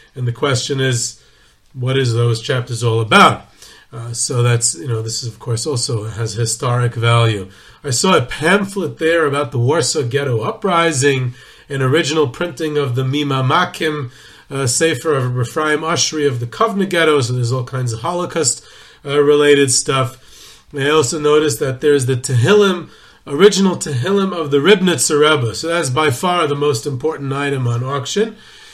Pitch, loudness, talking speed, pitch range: 140 Hz, -16 LUFS, 170 wpm, 120-155 Hz